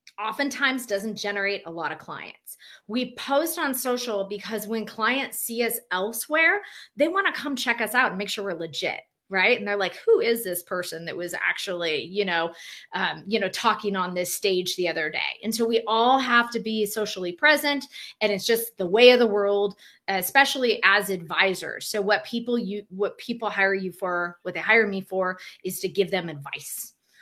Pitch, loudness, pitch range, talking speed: 210 Hz, -24 LUFS, 185-235 Hz, 200 wpm